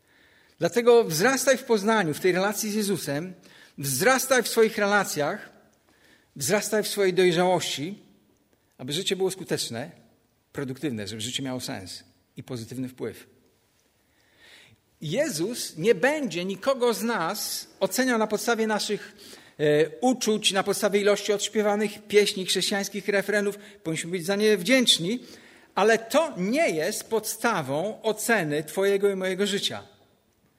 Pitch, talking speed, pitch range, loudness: 200 Hz, 120 wpm, 165-220 Hz, -25 LUFS